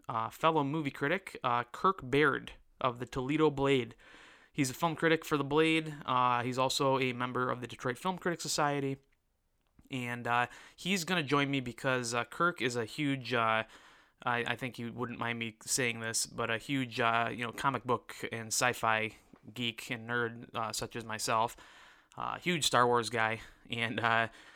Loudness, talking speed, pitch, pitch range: -32 LUFS, 185 wpm, 125 Hz, 115-140 Hz